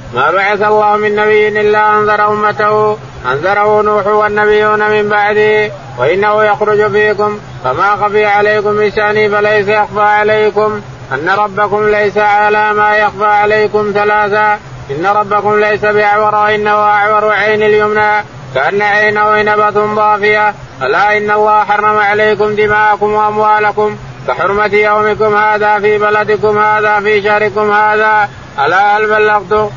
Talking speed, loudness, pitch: 125 wpm, -10 LUFS, 210 Hz